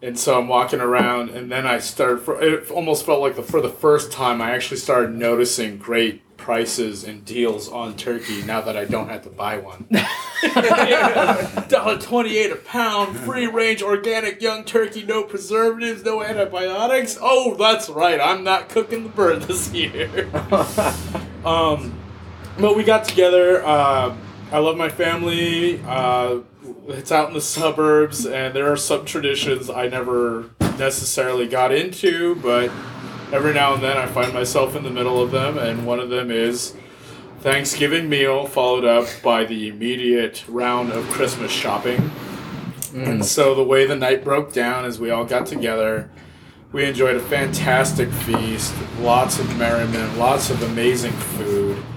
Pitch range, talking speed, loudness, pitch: 120-170 Hz, 165 wpm, -19 LUFS, 130 Hz